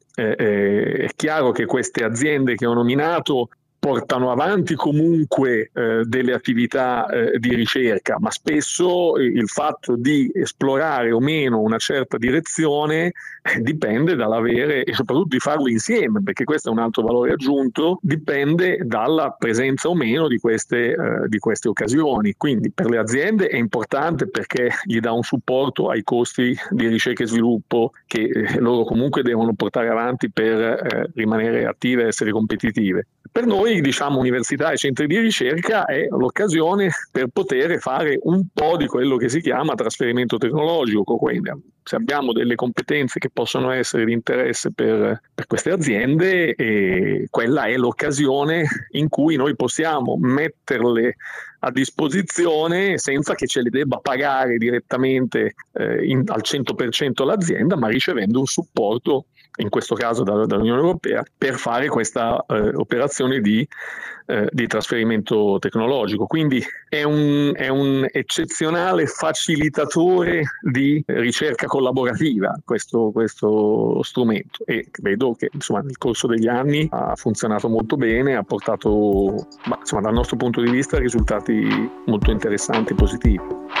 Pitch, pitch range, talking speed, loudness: 130 Hz, 115-155 Hz, 145 wpm, -20 LUFS